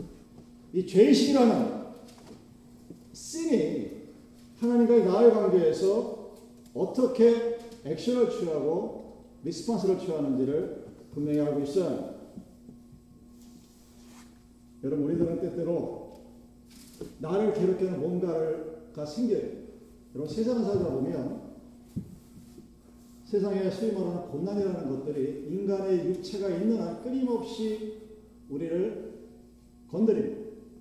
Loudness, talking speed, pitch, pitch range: -28 LUFS, 220 characters per minute, 195 Hz, 150-230 Hz